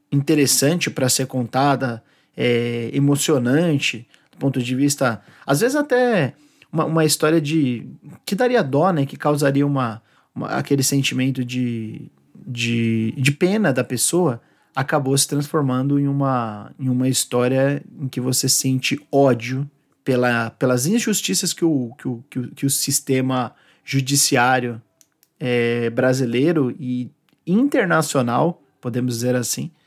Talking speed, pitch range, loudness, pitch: 135 wpm, 125-150 Hz, -20 LUFS, 135 Hz